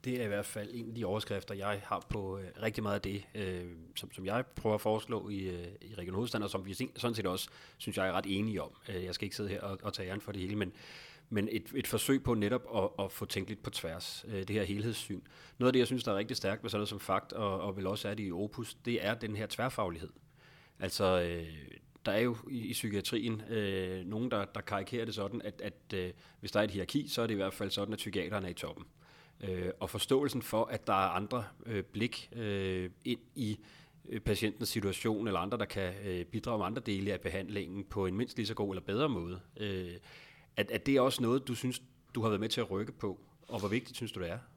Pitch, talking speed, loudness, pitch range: 105 Hz, 255 wpm, -36 LUFS, 95-120 Hz